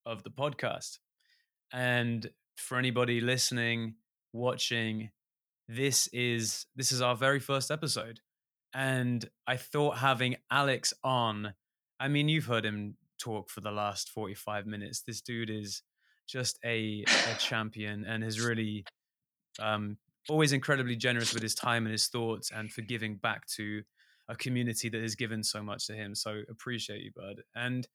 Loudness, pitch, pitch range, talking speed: -32 LUFS, 115 Hz, 110-125 Hz, 150 wpm